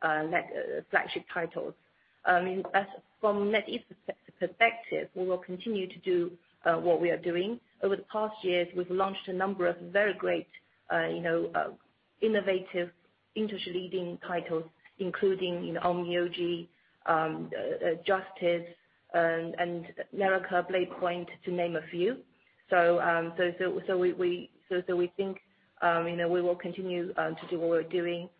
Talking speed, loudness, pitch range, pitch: 165 wpm, -31 LUFS, 175-190 Hz, 180 Hz